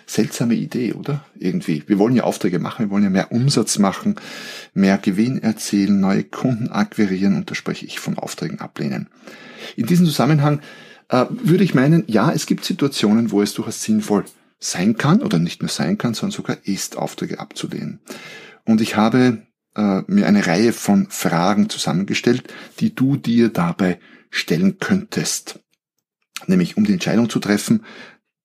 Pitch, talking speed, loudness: 125 Hz, 160 wpm, -19 LUFS